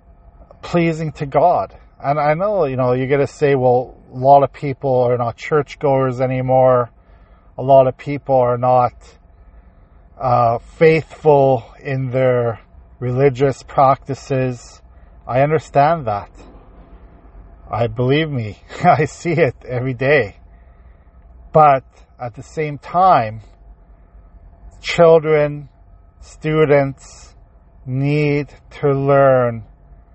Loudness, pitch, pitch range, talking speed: -16 LUFS, 125 Hz, 85-140 Hz, 105 wpm